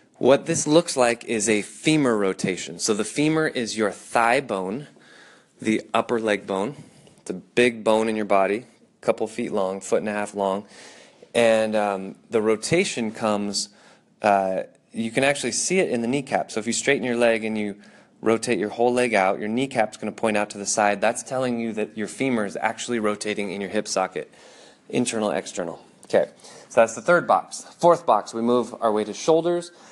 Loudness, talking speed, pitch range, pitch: -23 LUFS, 200 wpm, 105-125 Hz, 110 Hz